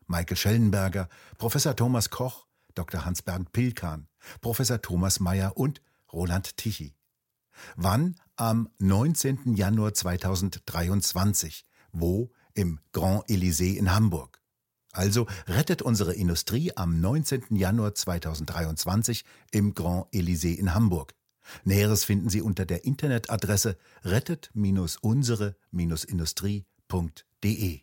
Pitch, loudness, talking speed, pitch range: 100 Hz, -27 LUFS, 95 wpm, 90-115 Hz